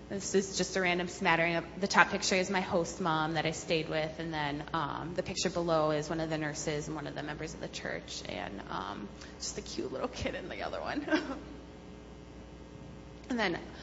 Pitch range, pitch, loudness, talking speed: 150-185 Hz, 165 Hz, -33 LUFS, 215 wpm